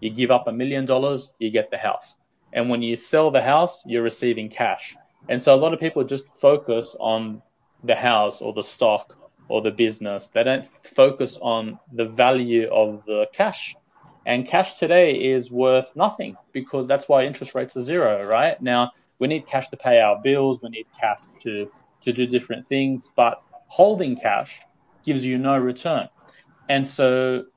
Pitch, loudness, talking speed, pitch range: 130 Hz, -21 LUFS, 185 wpm, 115-140 Hz